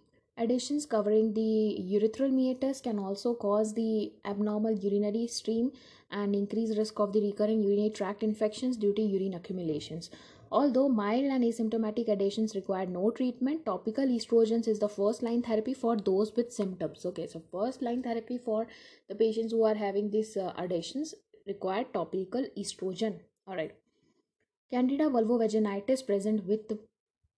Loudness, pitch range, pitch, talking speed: -31 LUFS, 200-235 Hz, 220 Hz, 140 wpm